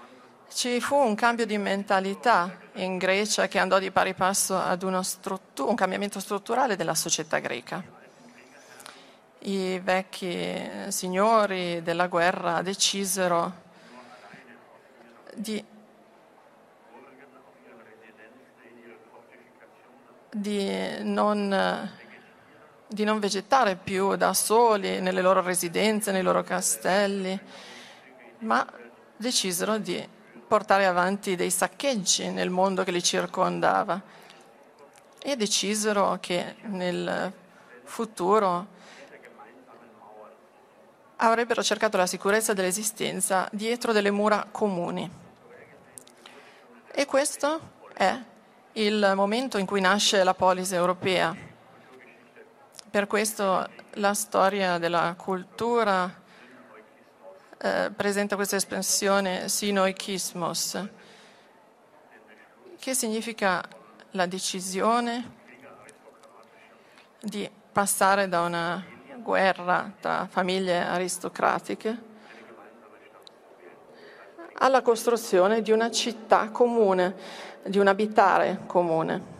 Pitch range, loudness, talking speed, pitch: 185-215 Hz, -25 LUFS, 85 wpm, 195 Hz